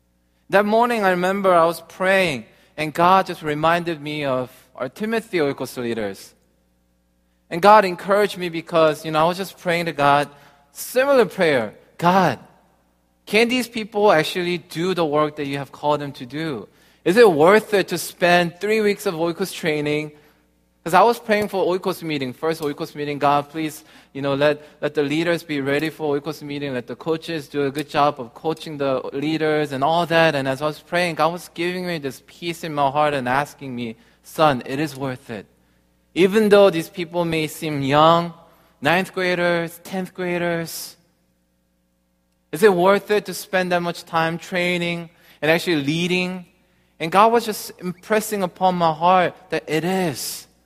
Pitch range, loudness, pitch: 145-180 Hz, -20 LUFS, 160 Hz